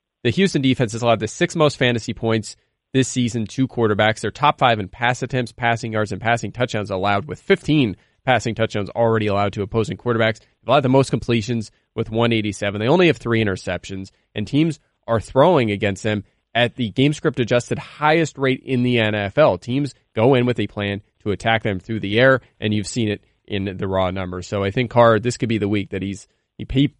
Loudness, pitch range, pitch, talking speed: -20 LUFS, 105-130 Hz, 115 Hz, 215 wpm